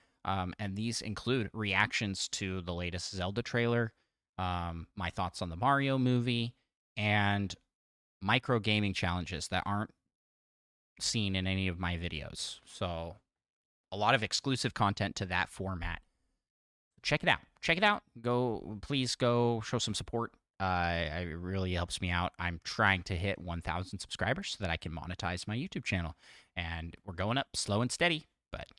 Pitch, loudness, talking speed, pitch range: 100 Hz, -33 LUFS, 165 wpm, 90-120 Hz